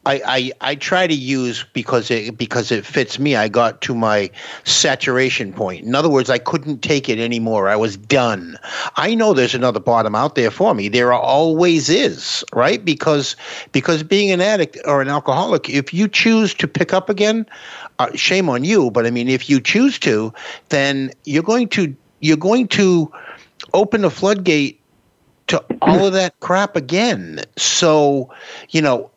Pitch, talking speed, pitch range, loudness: 145 Hz, 180 wpm, 125-185 Hz, -16 LUFS